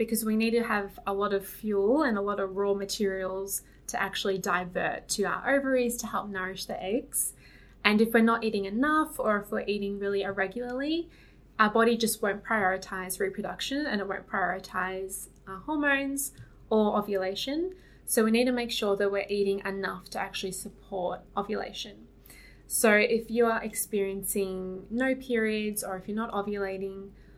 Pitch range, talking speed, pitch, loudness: 195-230 Hz, 170 wpm, 205 Hz, -29 LUFS